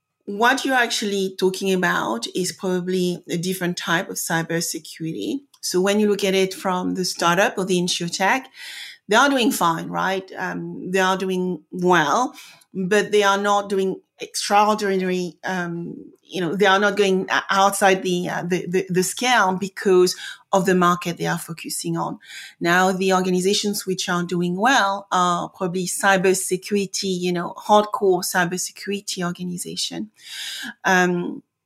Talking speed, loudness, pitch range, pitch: 150 wpm, -21 LUFS, 180-200 Hz, 185 Hz